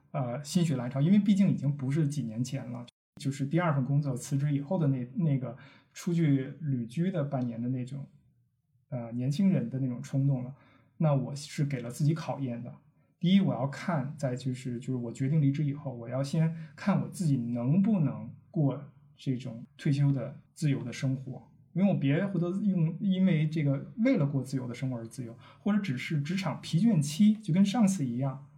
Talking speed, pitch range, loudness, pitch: 290 characters per minute, 130-165 Hz, -30 LUFS, 140 Hz